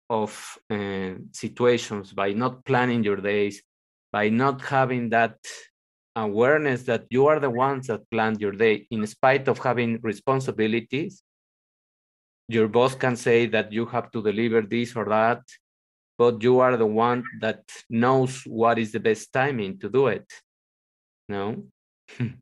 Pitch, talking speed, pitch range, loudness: 115 Hz, 145 wpm, 105-125 Hz, -24 LUFS